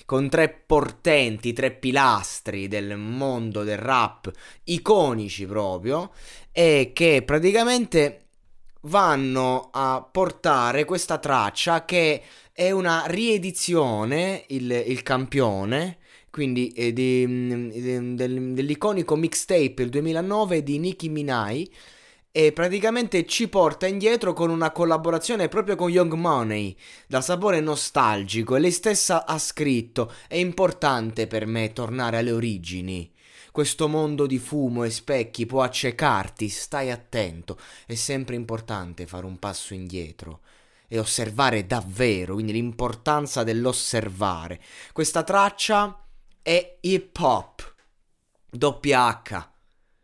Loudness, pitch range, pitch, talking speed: -23 LUFS, 115-165 Hz, 130 Hz, 110 wpm